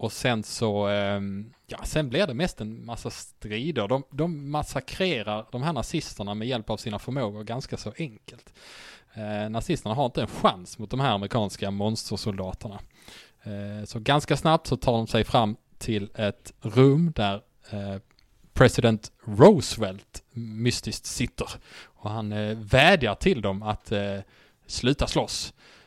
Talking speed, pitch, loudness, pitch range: 150 wpm, 110 Hz, -26 LUFS, 105-130 Hz